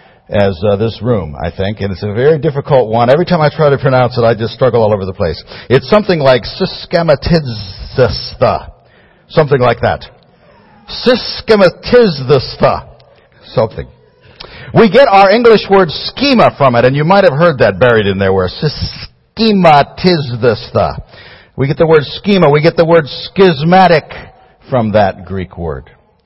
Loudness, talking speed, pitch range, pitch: -11 LUFS, 155 wpm, 110-180 Hz, 145 Hz